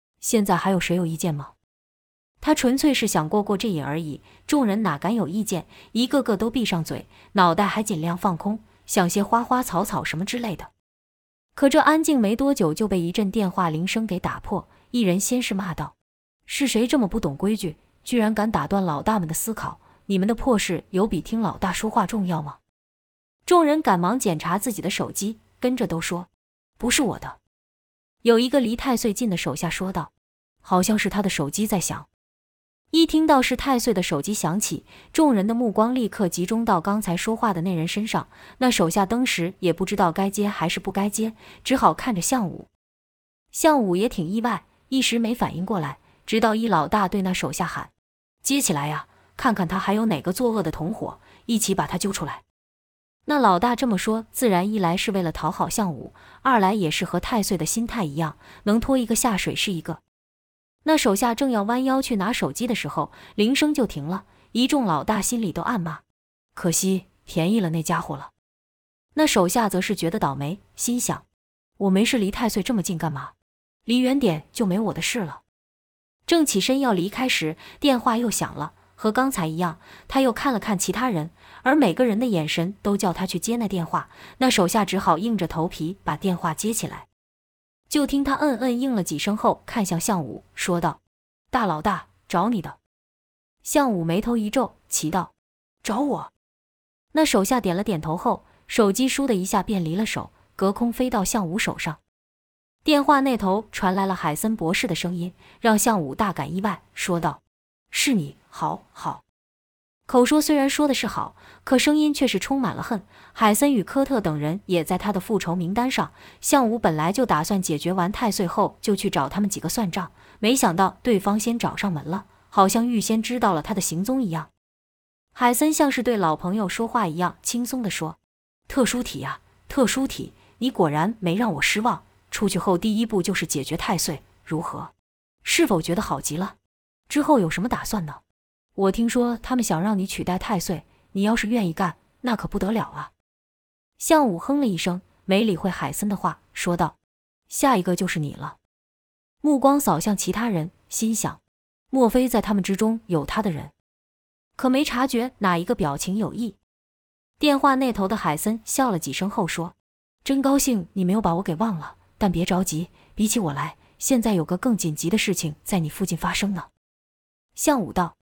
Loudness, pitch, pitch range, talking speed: -23 LUFS, 200 Hz, 170-235 Hz, 270 characters per minute